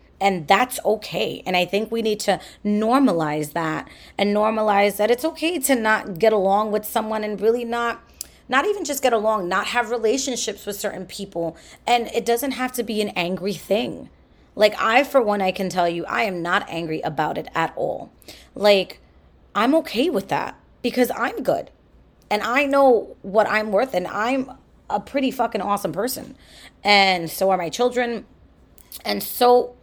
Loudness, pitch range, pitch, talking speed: -21 LUFS, 195-245 Hz, 215 Hz, 180 wpm